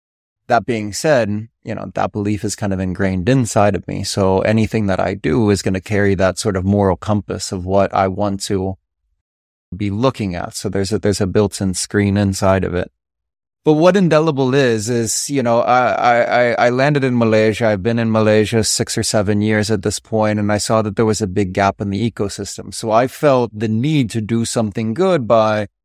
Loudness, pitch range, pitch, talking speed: -16 LUFS, 100-115 Hz, 105 Hz, 215 wpm